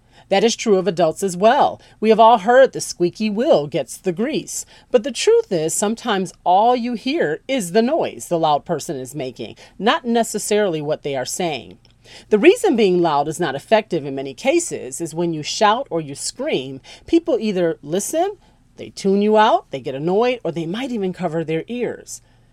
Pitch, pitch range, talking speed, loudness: 185 Hz, 155-225 Hz, 195 wpm, -19 LUFS